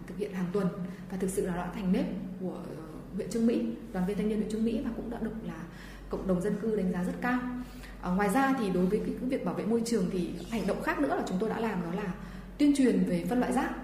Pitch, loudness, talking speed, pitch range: 205 Hz, -31 LUFS, 285 wpm, 190-230 Hz